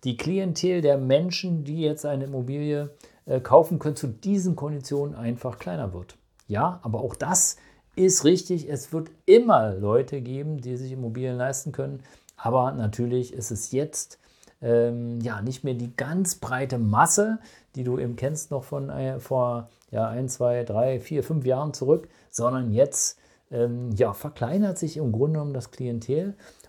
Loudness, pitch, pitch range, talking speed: -25 LUFS, 135 Hz, 120-150 Hz, 160 wpm